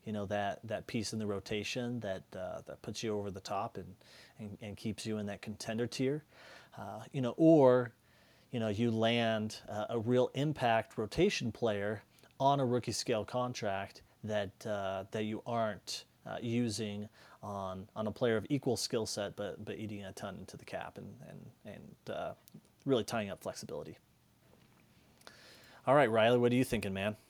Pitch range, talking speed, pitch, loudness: 105-120 Hz, 180 wpm, 110 Hz, -35 LUFS